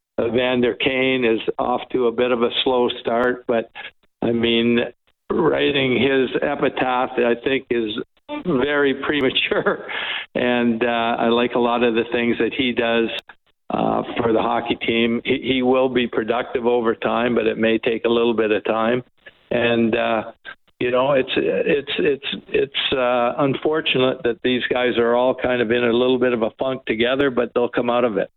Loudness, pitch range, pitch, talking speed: -20 LUFS, 115-130 Hz, 120 Hz, 185 wpm